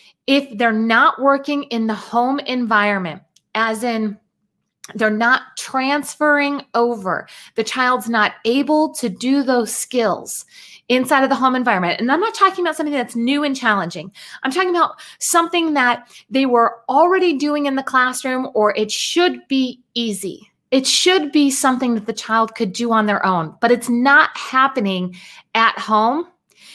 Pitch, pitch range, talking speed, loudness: 250 Hz, 220-280 Hz, 160 wpm, -17 LUFS